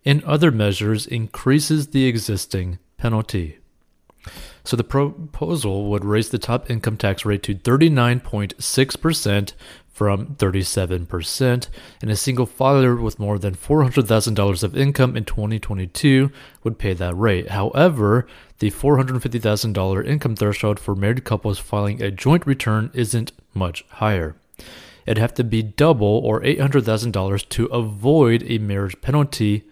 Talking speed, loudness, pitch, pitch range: 130 wpm, -20 LUFS, 110 Hz, 100-130 Hz